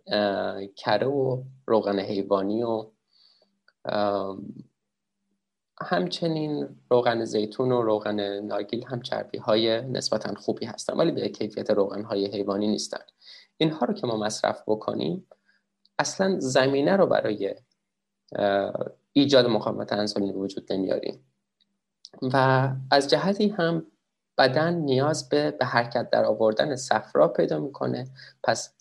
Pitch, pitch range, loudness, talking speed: 120 Hz, 105-150 Hz, -25 LUFS, 110 wpm